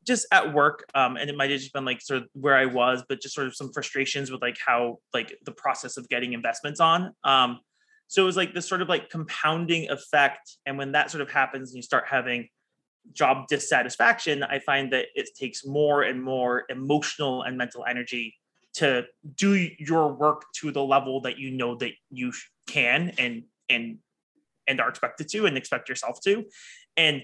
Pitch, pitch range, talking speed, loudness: 140 Hz, 125-155 Hz, 200 wpm, -25 LUFS